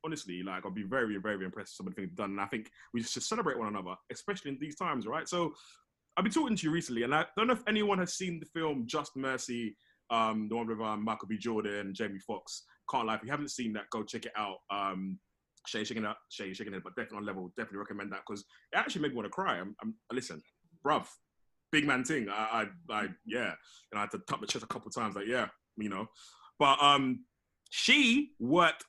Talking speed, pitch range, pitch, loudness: 245 wpm, 105-165 Hz, 115 Hz, -34 LUFS